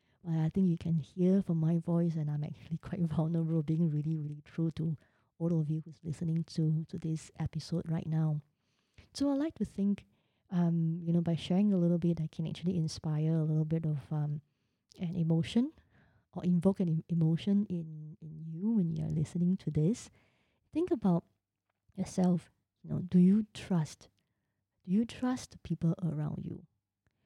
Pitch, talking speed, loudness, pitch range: 165 Hz, 175 wpm, -33 LUFS, 155-180 Hz